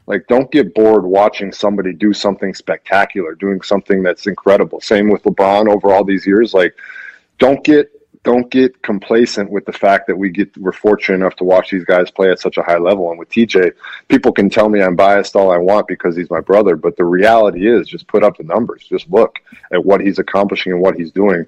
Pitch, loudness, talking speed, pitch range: 100 Hz, -13 LUFS, 225 wpm, 95-105 Hz